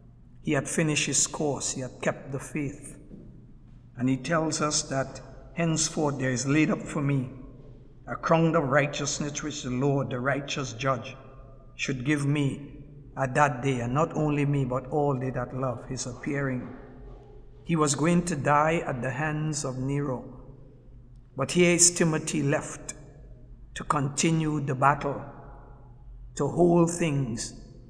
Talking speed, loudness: 155 wpm, -27 LUFS